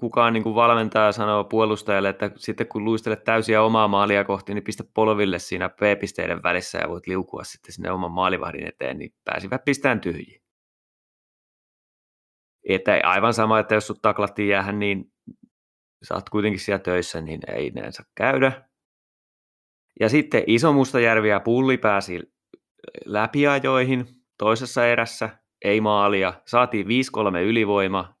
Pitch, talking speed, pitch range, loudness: 110 Hz, 135 wpm, 100-115 Hz, -22 LUFS